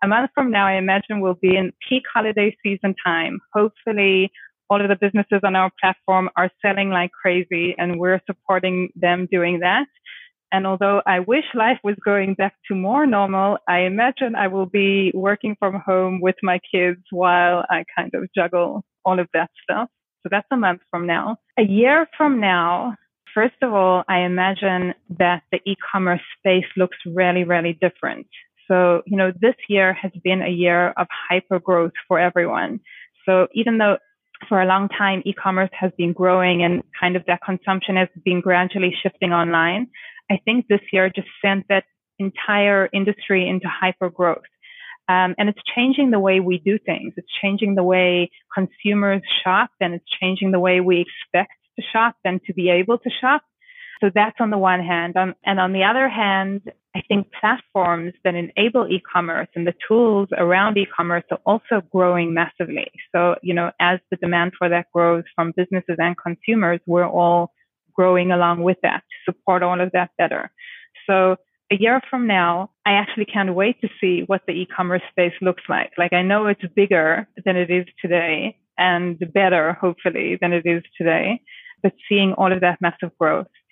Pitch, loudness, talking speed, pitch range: 190 Hz, -19 LUFS, 185 wpm, 180-205 Hz